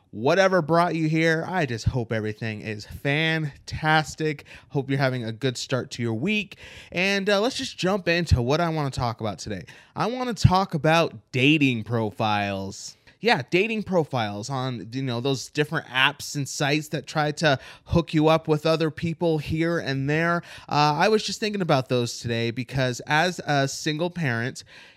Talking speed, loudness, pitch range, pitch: 180 wpm, -24 LUFS, 120-165 Hz, 150 Hz